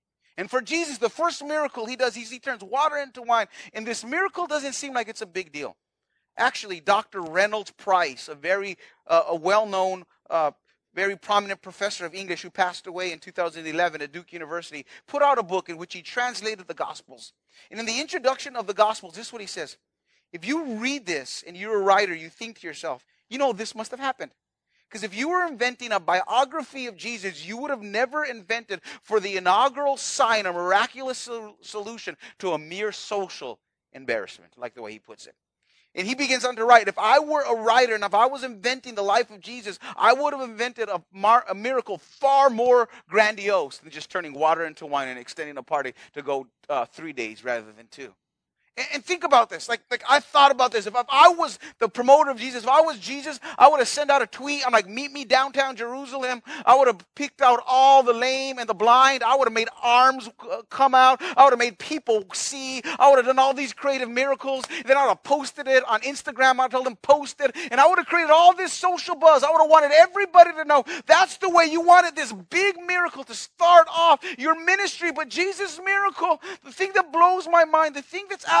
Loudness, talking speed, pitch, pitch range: -21 LUFS, 225 wpm, 250 Hz, 205-285 Hz